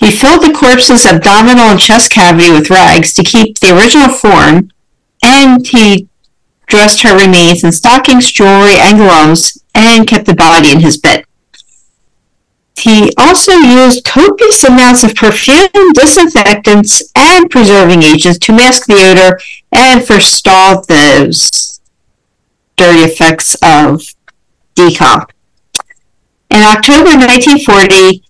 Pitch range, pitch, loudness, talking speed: 185-255 Hz, 210 Hz, -3 LUFS, 120 wpm